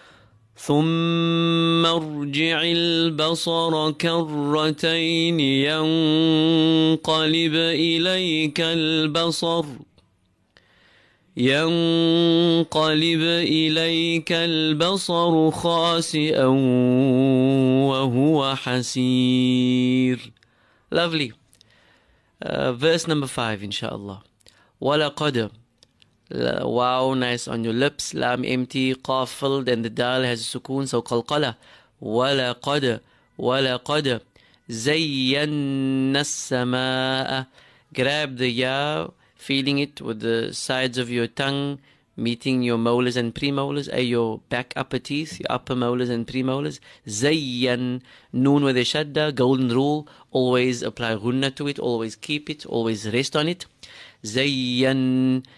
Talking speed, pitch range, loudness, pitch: 100 wpm, 125-155 Hz, -22 LUFS, 135 Hz